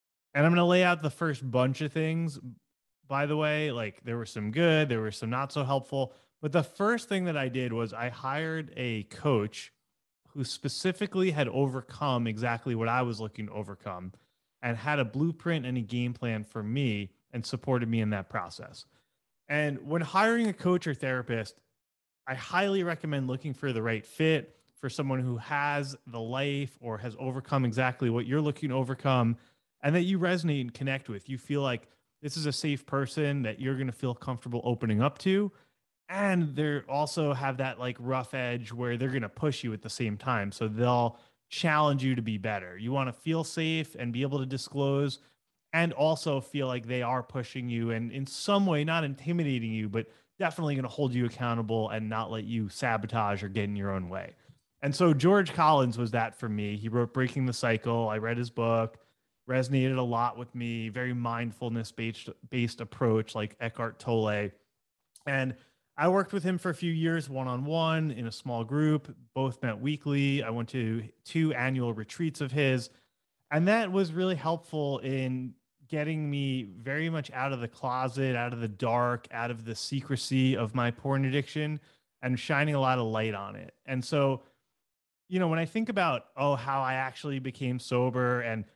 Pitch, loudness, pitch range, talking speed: 130 Hz, -30 LUFS, 115-150 Hz, 195 wpm